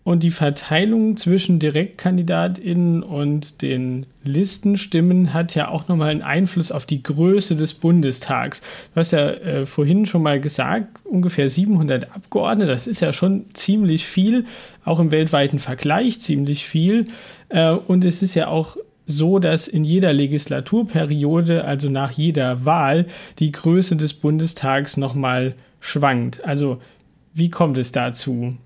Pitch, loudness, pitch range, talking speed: 165 Hz, -19 LUFS, 145-180 Hz, 140 wpm